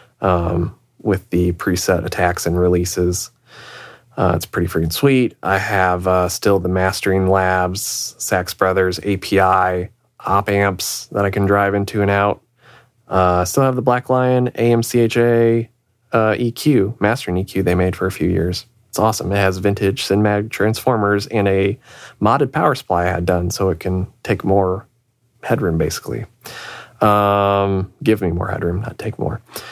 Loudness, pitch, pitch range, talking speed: -17 LUFS, 100 Hz, 90-115 Hz, 160 wpm